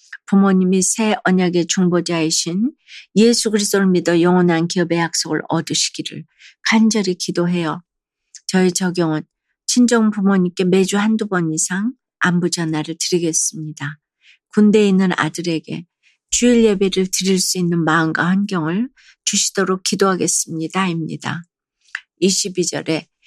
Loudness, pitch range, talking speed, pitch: -17 LUFS, 165-195 Hz, 290 characters per minute, 180 Hz